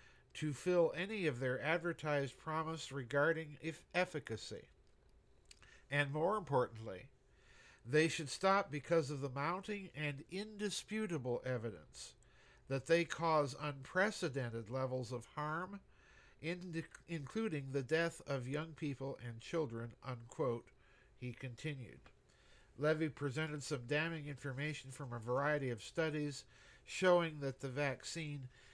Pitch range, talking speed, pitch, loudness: 130-165 Hz, 115 wpm, 150 Hz, -40 LUFS